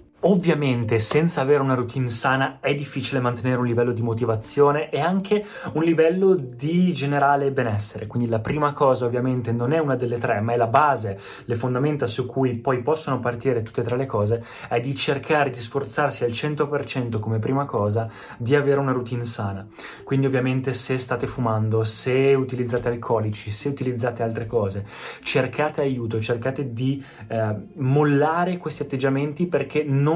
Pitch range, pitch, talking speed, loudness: 120-145 Hz, 130 Hz, 165 wpm, -23 LUFS